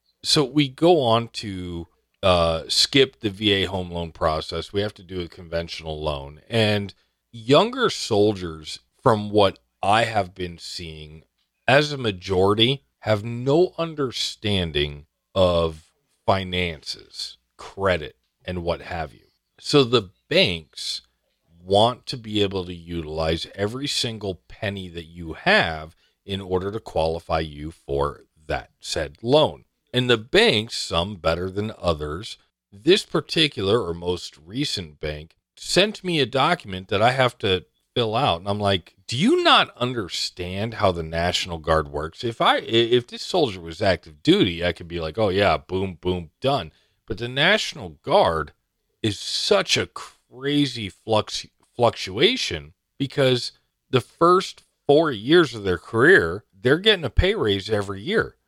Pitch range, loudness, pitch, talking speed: 85-115 Hz, -22 LUFS, 95 Hz, 145 wpm